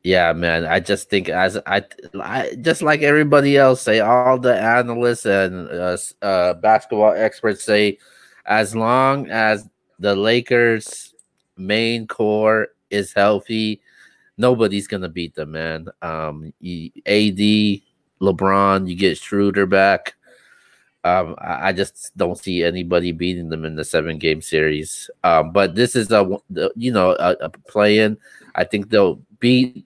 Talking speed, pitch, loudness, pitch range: 150 wpm, 105 Hz, -18 LUFS, 90-115 Hz